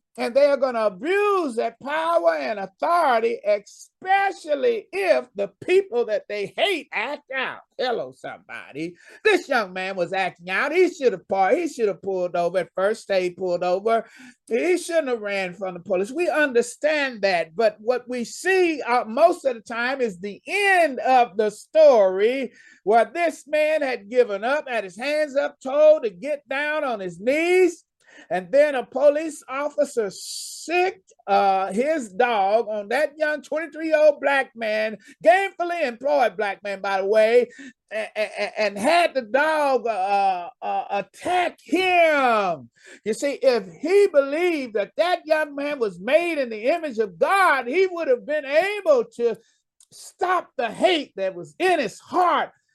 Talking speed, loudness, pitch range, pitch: 165 wpm, -22 LUFS, 220-320 Hz, 275 Hz